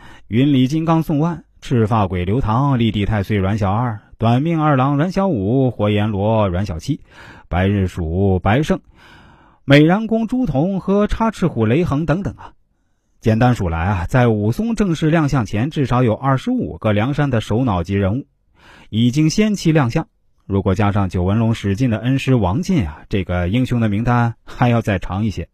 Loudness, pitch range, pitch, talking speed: -17 LUFS, 100-145 Hz, 120 Hz, 265 characters per minute